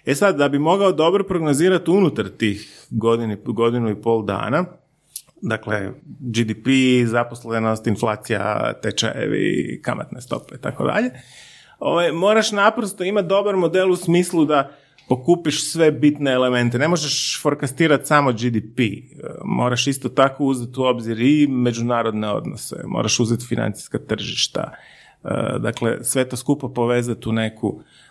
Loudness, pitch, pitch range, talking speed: -20 LUFS, 130 Hz, 115-155 Hz, 130 wpm